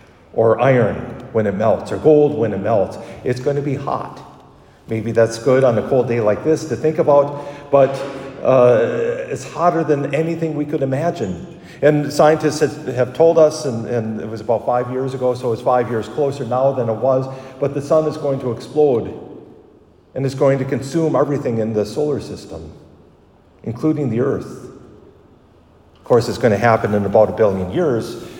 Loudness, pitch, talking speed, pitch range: -17 LUFS, 135 Hz, 190 wpm, 115-150 Hz